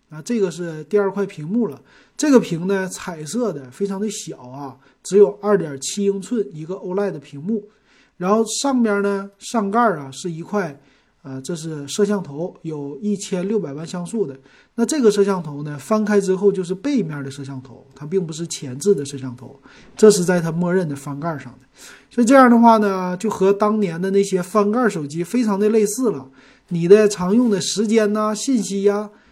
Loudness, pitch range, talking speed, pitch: -19 LUFS, 155-210 Hz, 290 characters per minute, 195 Hz